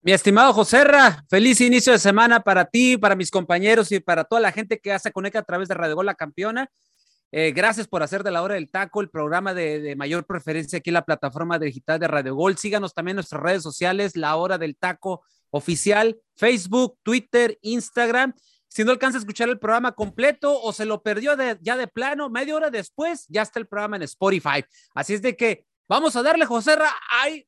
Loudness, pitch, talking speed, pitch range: -20 LUFS, 210 Hz, 215 wpm, 180-240 Hz